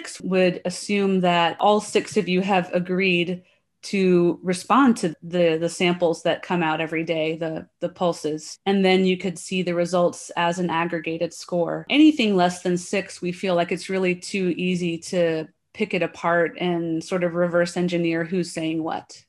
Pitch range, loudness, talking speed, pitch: 170-185 Hz, -22 LUFS, 175 wpm, 175 Hz